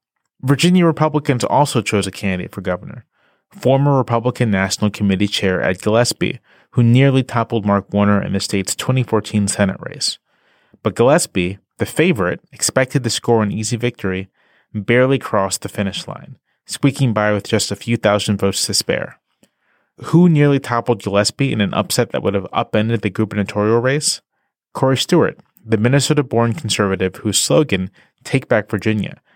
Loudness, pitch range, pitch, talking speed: -17 LUFS, 100-130 Hz, 110 Hz, 155 wpm